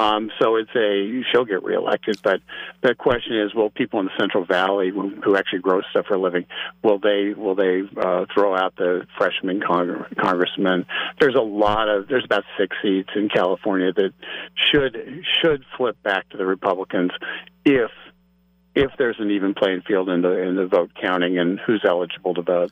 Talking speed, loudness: 190 wpm, -21 LUFS